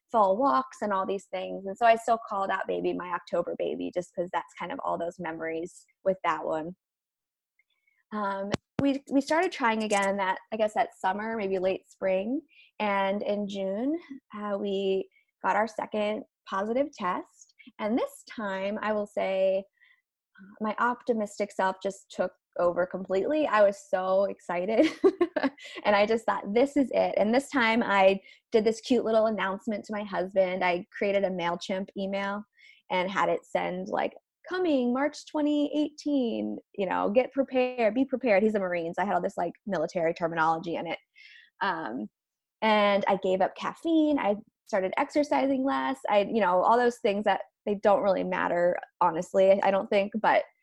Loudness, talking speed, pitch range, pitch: -28 LUFS, 170 wpm, 190-255 Hz, 205 Hz